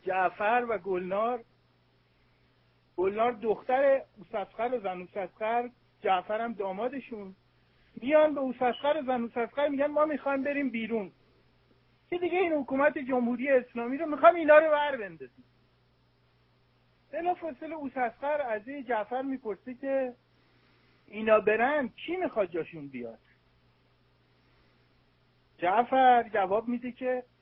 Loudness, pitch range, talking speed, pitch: -29 LUFS, 195-275 Hz, 115 wpm, 240 Hz